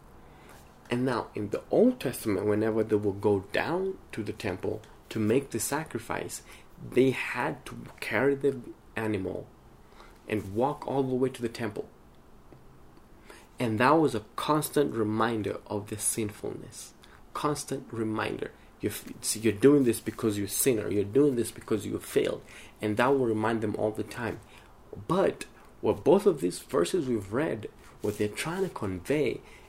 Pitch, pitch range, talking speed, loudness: 110 Hz, 105-130 Hz, 155 wpm, -29 LUFS